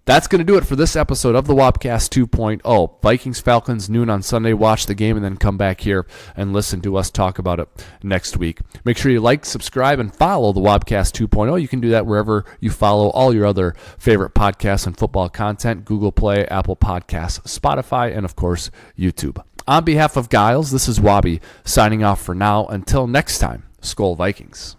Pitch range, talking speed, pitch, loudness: 95-120 Hz, 205 wpm, 105 Hz, -17 LUFS